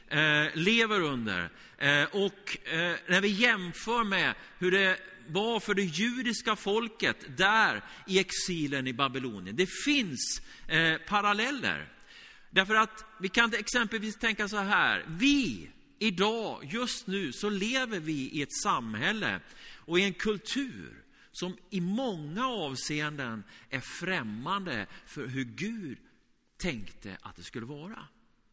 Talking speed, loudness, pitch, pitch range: 120 wpm, -29 LUFS, 200 Hz, 160-225 Hz